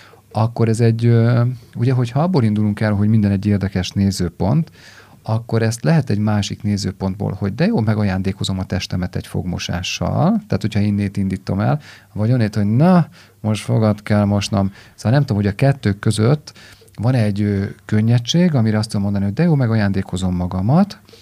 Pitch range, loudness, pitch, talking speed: 100-120 Hz, -18 LUFS, 105 Hz, 170 wpm